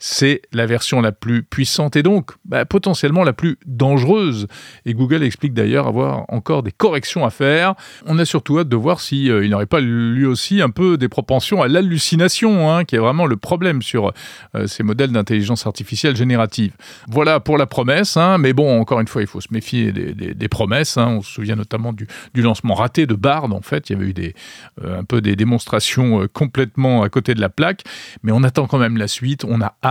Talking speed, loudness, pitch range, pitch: 225 wpm, -17 LUFS, 110-150 Hz, 125 Hz